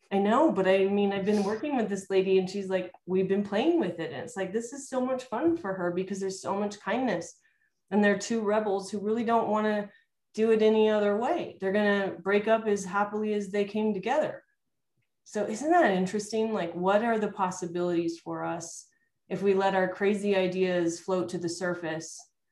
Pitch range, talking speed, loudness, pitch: 190-215 Hz, 215 wpm, -28 LUFS, 200 Hz